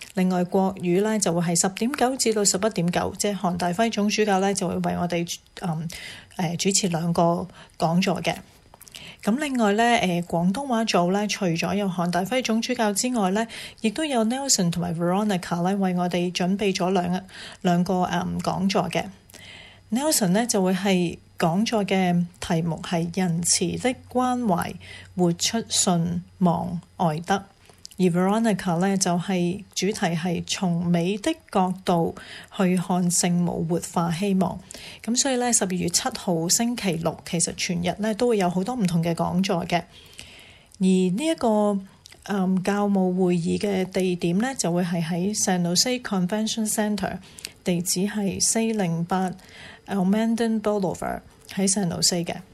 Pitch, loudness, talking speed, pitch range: 185 Hz, -23 LUFS, 285 characters per minute, 175-210 Hz